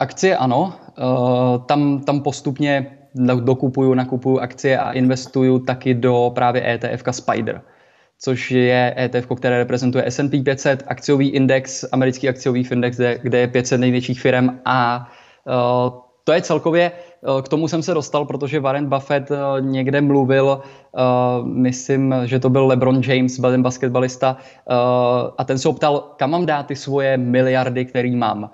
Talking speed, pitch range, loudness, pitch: 140 wpm, 125-140 Hz, -18 LUFS, 130 Hz